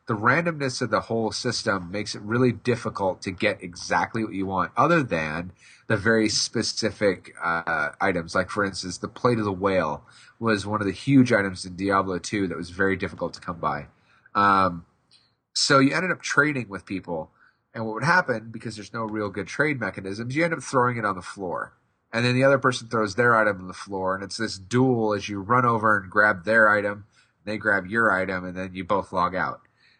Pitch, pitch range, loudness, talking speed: 105 Hz, 95-120 Hz, -24 LUFS, 215 wpm